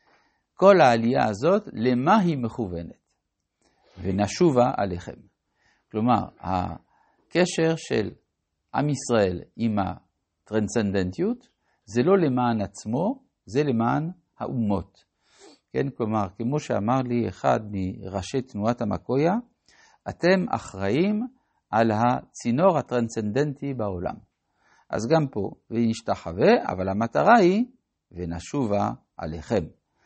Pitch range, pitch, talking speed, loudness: 100-160 Hz, 120 Hz, 95 wpm, -24 LUFS